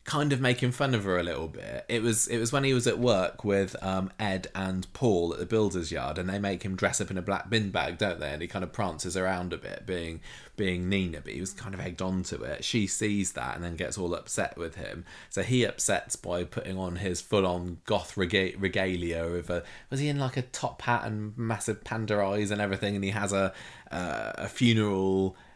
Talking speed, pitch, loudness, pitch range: 245 wpm, 95 Hz, -30 LUFS, 90-110 Hz